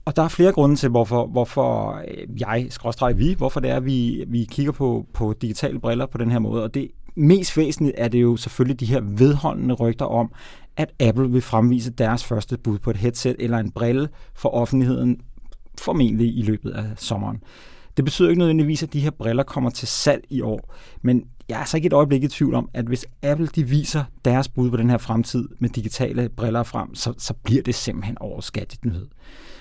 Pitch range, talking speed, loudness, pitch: 115-140 Hz, 210 wpm, -21 LUFS, 125 Hz